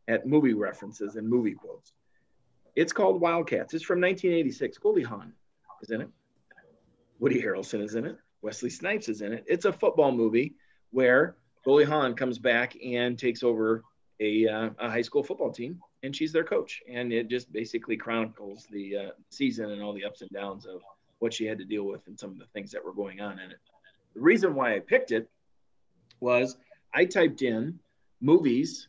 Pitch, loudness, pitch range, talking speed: 120 Hz, -28 LUFS, 110-150 Hz, 195 wpm